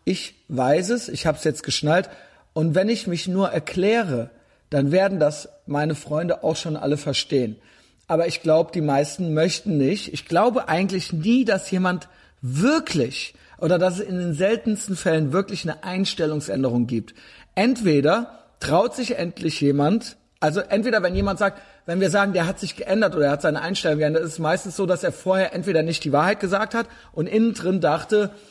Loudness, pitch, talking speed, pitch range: -22 LUFS, 170 Hz, 185 wpm, 150-195 Hz